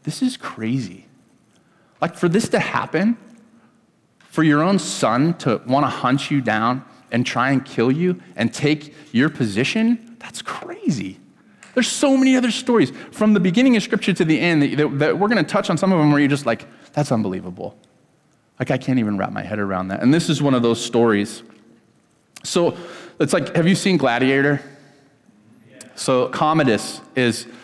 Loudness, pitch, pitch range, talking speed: -19 LUFS, 145 Hz, 120-195 Hz, 180 wpm